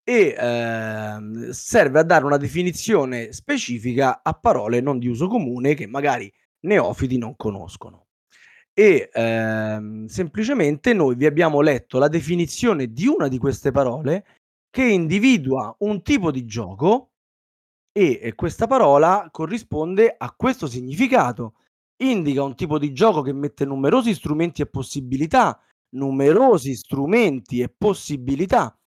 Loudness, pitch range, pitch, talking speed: -20 LUFS, 125-205 Hz, 145 Hz, 130 wpm